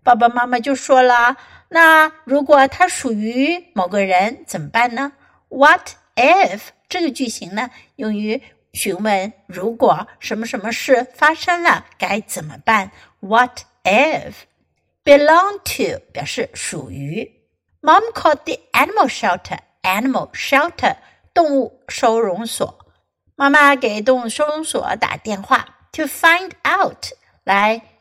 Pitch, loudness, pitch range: 255 Hz, -16 LUFS, 220-300 Hz